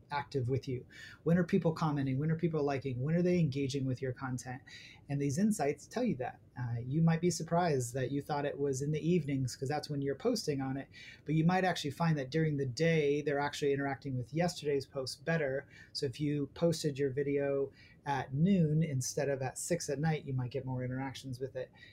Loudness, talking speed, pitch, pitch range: -34 LUFS, 220 wpm, 140 Hz, 135-160 Hz